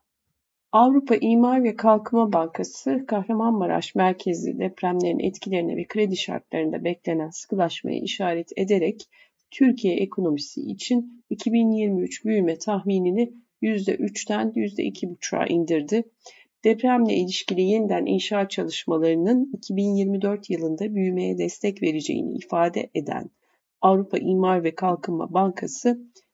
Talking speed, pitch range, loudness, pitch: 95 wpm, 180-230 Hz, -24 LUFS, 195 Hz